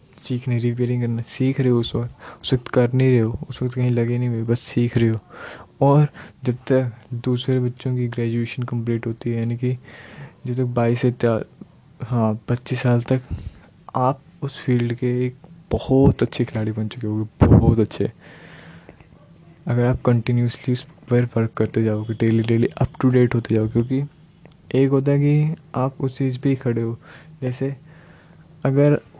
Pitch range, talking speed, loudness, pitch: 115-135 Hz, 175 wpm, -21 LUFS, 125 Hz